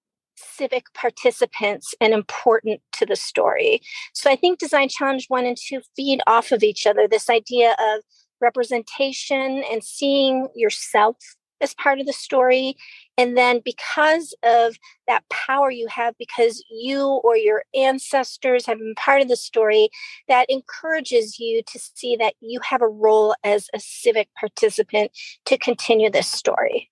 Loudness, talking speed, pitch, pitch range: -20 LUFS, 155 wpm, 250 Hz, 230-275 Hz